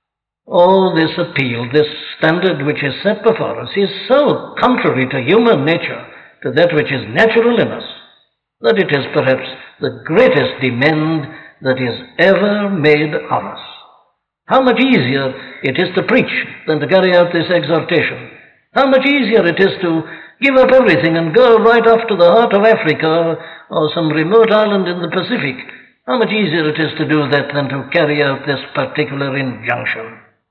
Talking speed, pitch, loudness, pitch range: 175 wpm, 165 Hz, -14 LUFS, 145-205 Hz